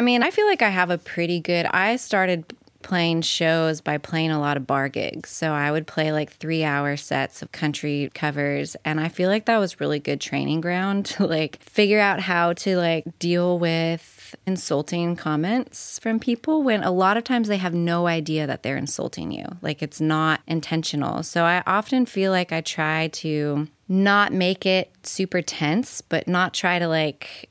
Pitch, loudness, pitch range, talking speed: 170 Hz, -23 LUFS, 155-190 Hz, 195 wpm